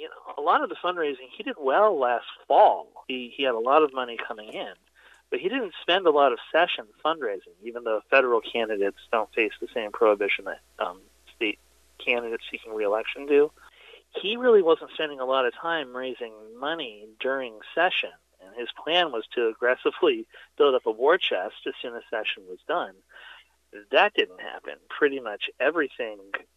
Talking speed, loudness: 185 wpm, -25 LUFS